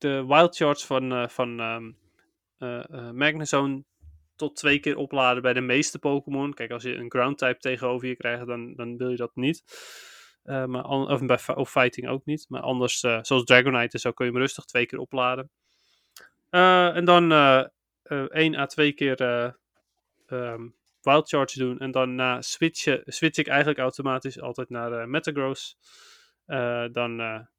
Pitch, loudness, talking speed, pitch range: 130 Hz, -24 LUFS, 175 wpm, 120-140 Hz